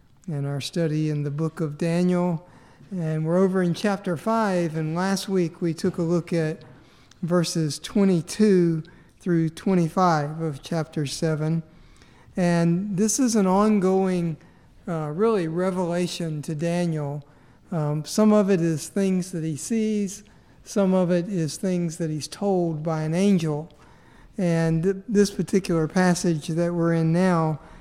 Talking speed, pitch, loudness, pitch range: 145 wpm, 170 Hz, -24 LUFS, 160-185 Hz